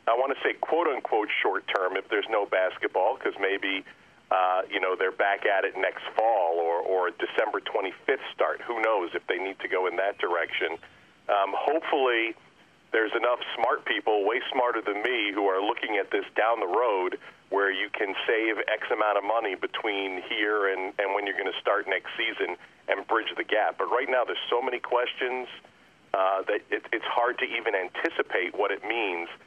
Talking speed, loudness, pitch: 200 wpm, -27 LUFS, 115 Hz